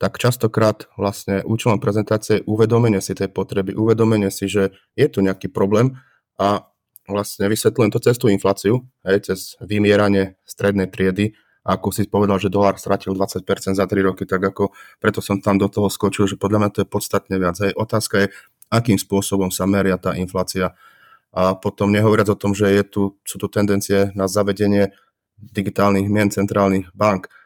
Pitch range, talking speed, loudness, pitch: 95-105 Hz, 175 wpm, -19 LUFS, 100 Hz